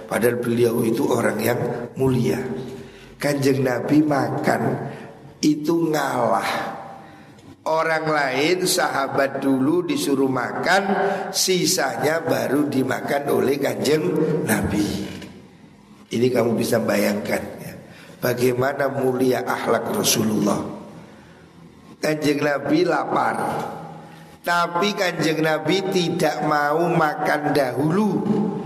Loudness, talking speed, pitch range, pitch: -21 LUFS, 90 wpm, 130-175 Hz, 145 Hz